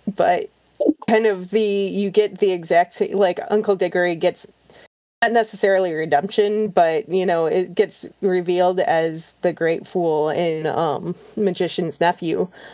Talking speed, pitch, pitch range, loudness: 135 wpm, 185 Hz, 175-205 Hz, -20 LUFS